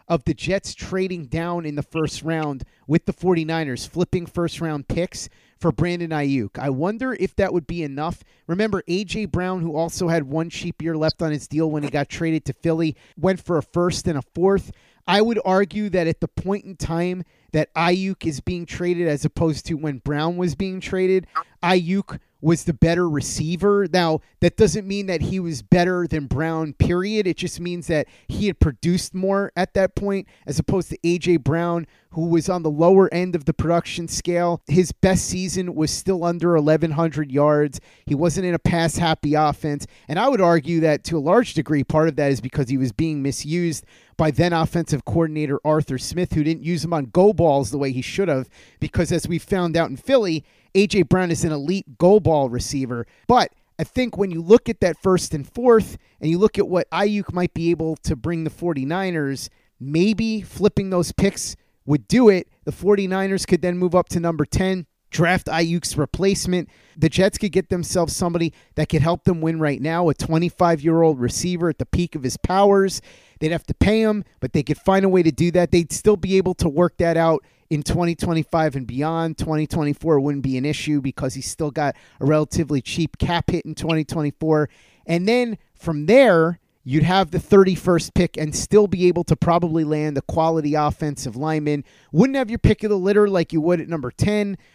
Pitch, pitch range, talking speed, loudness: 165 Hz, 155-180 Hz, 205 wpm, -21 LUFS